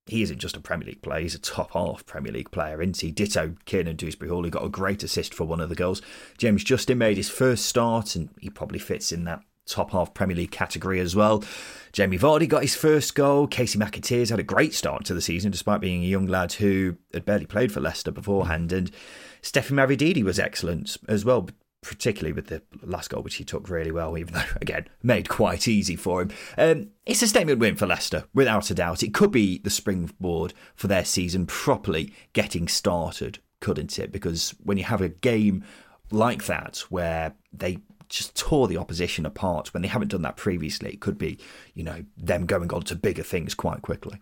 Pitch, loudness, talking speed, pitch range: 100 Hz, -25 LUFS, 215 wpm, 85-115 Hz